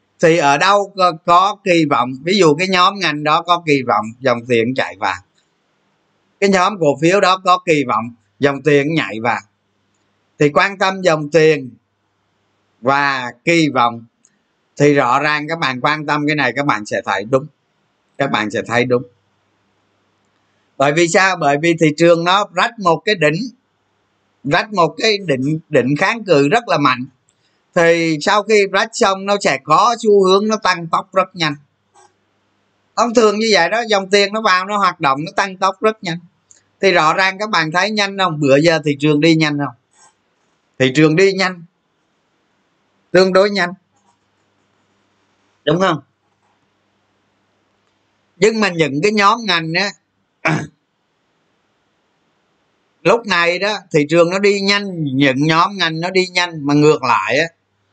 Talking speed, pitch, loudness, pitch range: 165 wpm, 155 Hz, -15 LUFS, 125-185 Hz